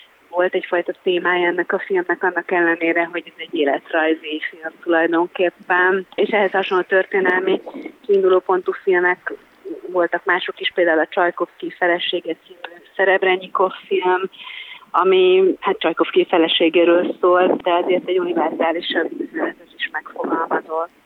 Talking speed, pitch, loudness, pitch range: 120 wpm, 180 Hz, -18 LUFS, 170-195 Hz